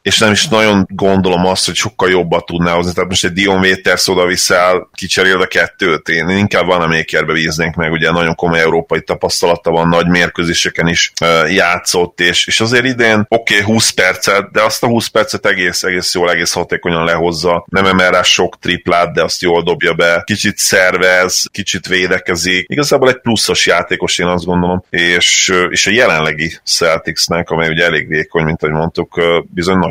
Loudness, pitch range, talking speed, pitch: -11 LUFS, 85-95 Hz, 185 wpm, 90 Hz